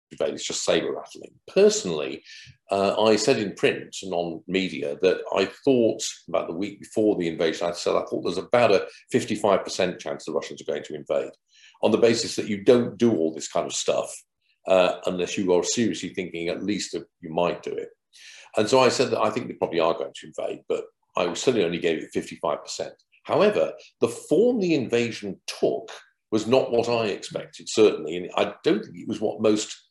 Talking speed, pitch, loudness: 205 wpm, 120 Hz, -24 LUFS